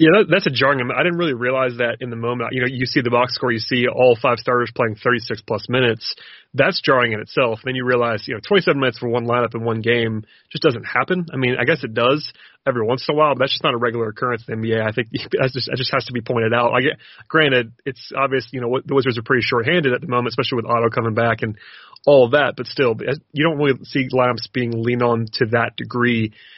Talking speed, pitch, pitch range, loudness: 270 wpm, 125 Hz, 120-135 Hz, -19 LUFS